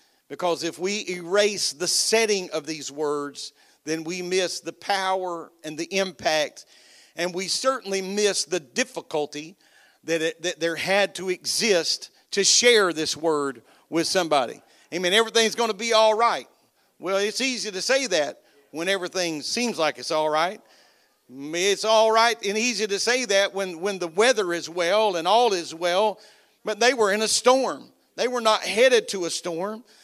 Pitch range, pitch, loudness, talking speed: 165-215 Hz, 190 Hz, -23 LUFS, 175 wpm